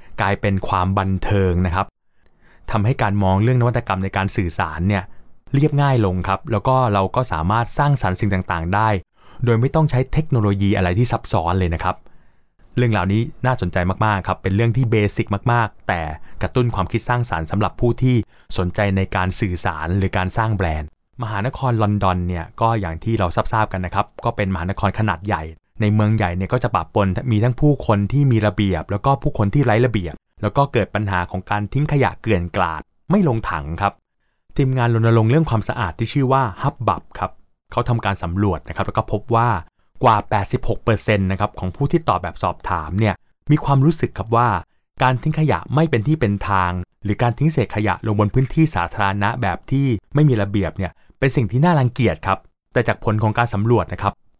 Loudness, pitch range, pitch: -19 LUFS, 95-120 Hz, 105 Hz